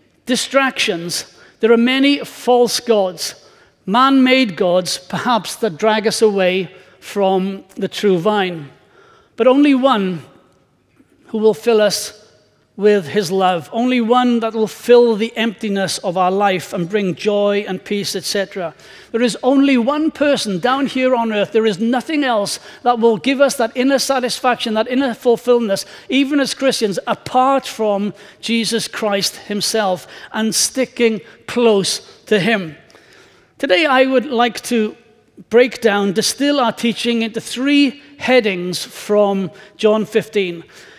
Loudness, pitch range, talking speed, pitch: -16 LUFS, 200-250 Hz, 140 wpm, 220 Hz